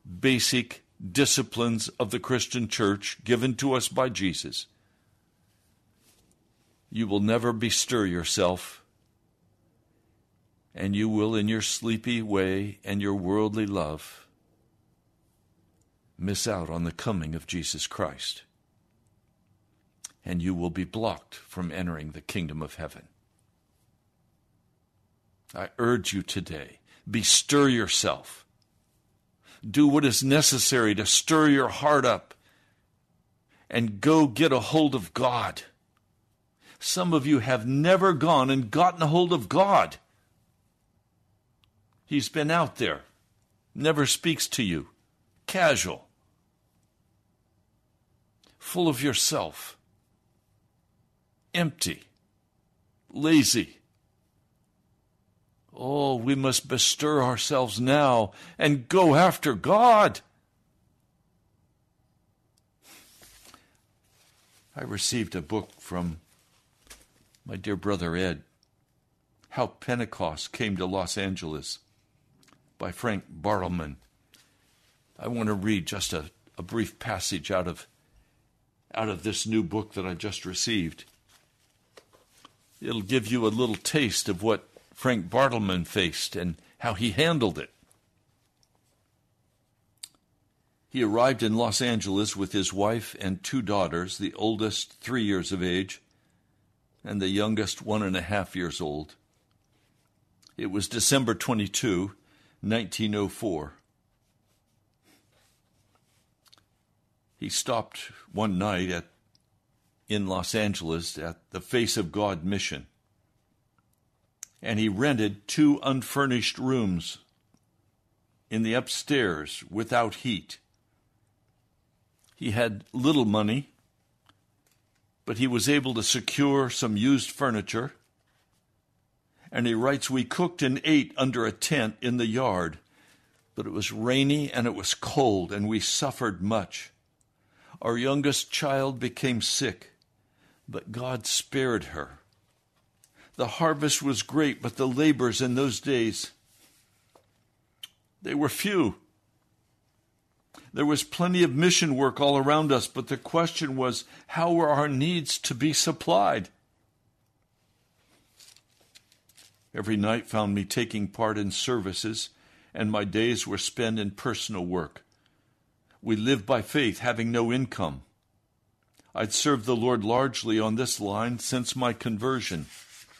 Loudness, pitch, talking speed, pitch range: -26 LUFS, 110 Hz, 115 wpm, 100-130 Hz